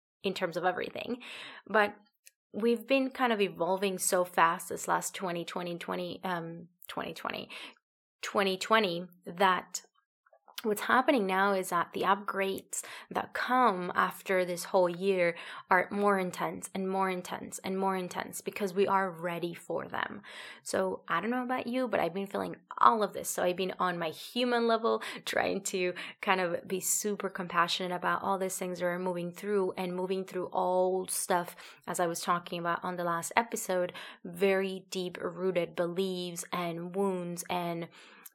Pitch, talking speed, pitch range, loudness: 185 Hz, 165 wpm, 180-200 Hz, -31 LUFS